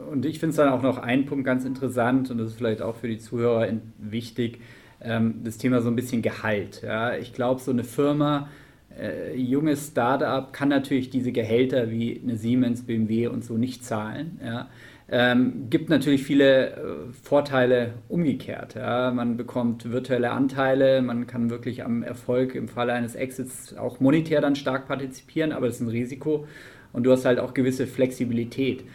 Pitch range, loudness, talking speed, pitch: 120-135 Hz, -25 LUFS, 165 wpm, 125 Hz